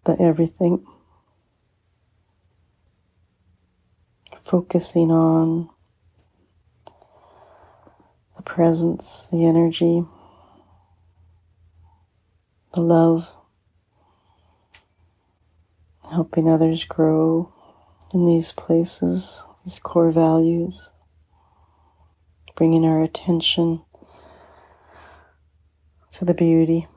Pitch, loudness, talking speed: 100 Hz, -19 LUFS, 55 wpm